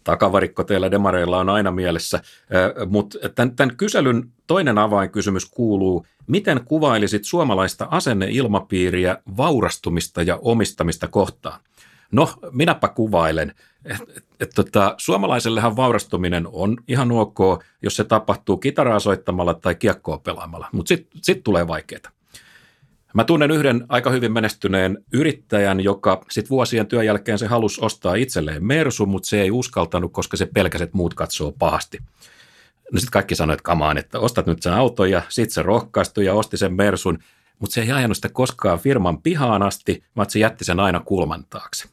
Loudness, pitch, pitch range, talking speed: -20 LUFS, 100 Hz, 95-120 Hz, 150 wpm